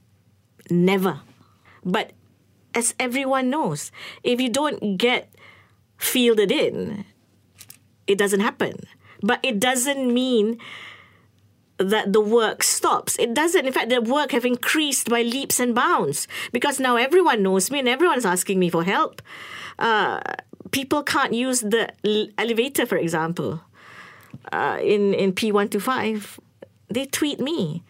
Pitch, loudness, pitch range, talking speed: 220 Hz, -21 LUFS, 165-255 Hz, 130 wpm